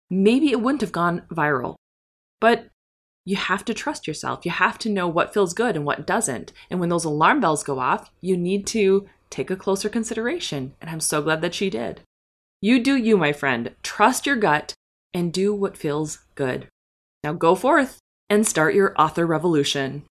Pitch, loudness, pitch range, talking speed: 180 Hz, -22 LUFS, 150-210 Hz, 190 wpm